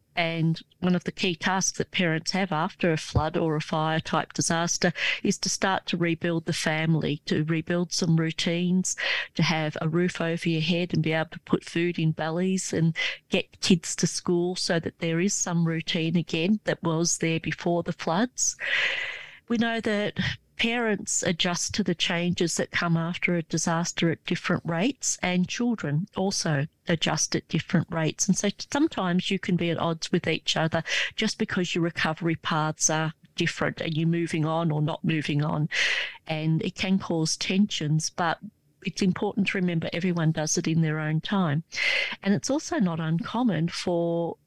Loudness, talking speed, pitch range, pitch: -26 LUFS, 180 wpm, 160-185 Hz, 170 Hz